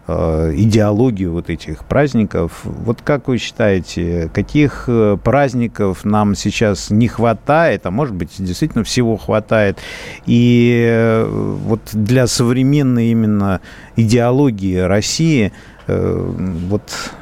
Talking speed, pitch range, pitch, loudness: 100 wpm, 95-120 Hz, 110 Hz, -15 LUFS